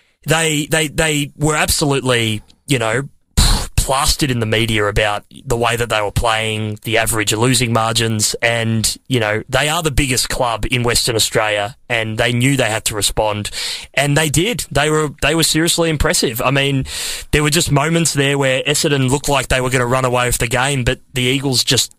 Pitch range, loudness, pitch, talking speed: 110-145 Hz, -16 LUFS, 125 Hz, 200 wpm